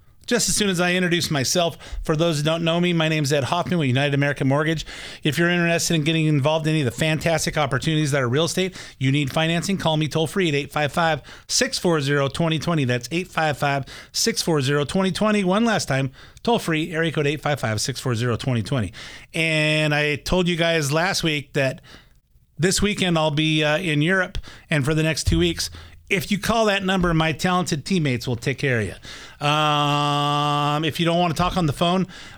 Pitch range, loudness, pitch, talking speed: 145-175 Hz, -21 LUFS, 155 Hz, 200 wpm